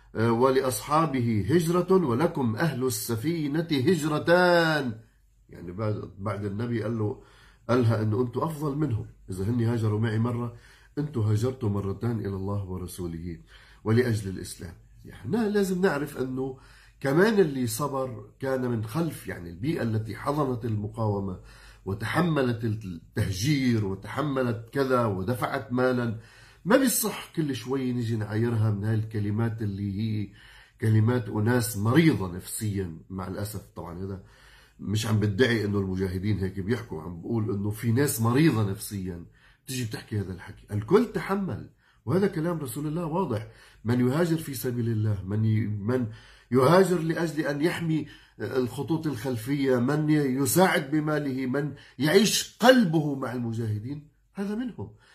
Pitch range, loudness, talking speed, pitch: 105-145 Hz, -27 LUFS, 125 wpm, 120 Hz